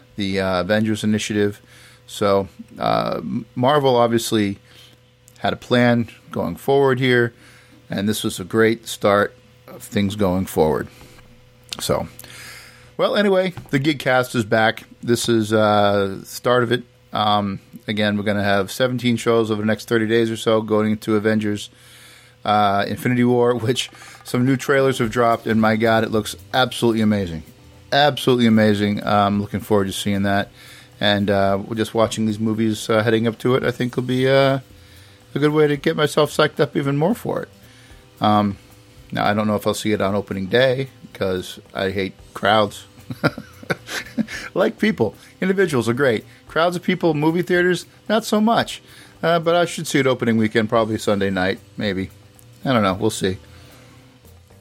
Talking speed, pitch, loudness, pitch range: 175 wpm, 115 Hz, -20 LUFS, 105-125 Hz